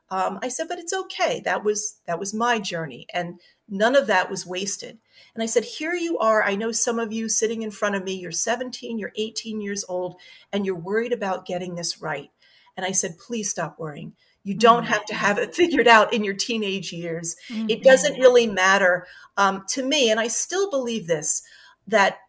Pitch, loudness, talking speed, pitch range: 215 Hz, -22 LUFS, 210 wpm, 190-235 Hz